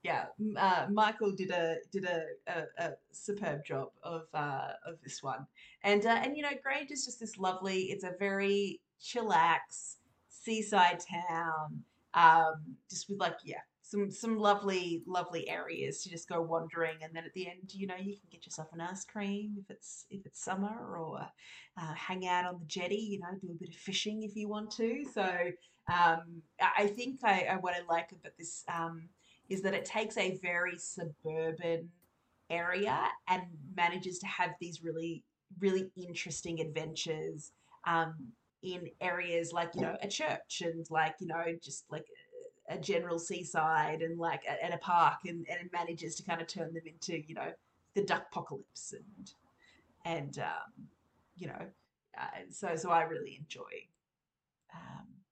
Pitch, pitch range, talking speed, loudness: 180 Hz, 165-200 Hz, 175 wpm, -35 LUFS